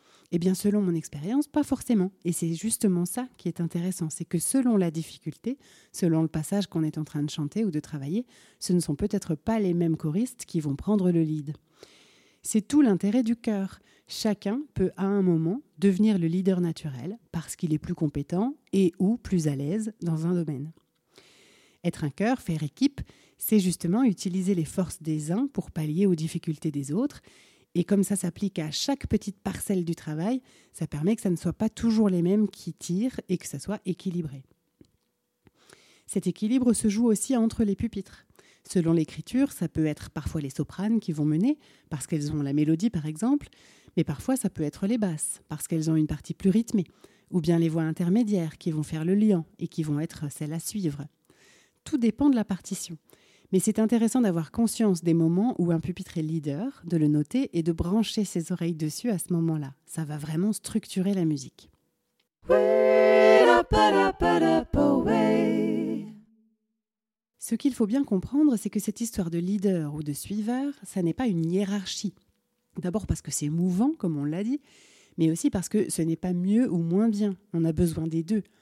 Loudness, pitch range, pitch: -27 LUFS, 160-215 Hz, 180 Hz